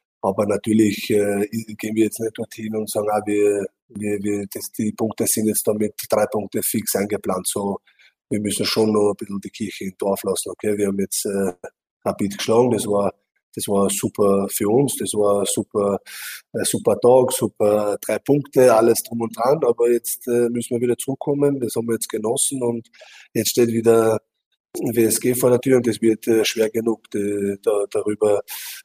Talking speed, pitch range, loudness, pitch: 195 wpm, 105-115 Hz, -20 LUFS, 110 Hz